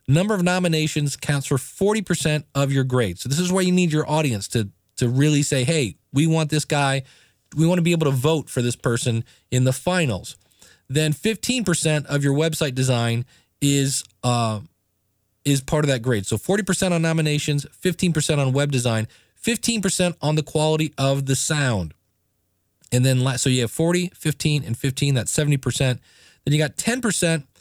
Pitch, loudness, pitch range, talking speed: 145 Hz, -21 LUFS, 125-160 Hz, 180 wpm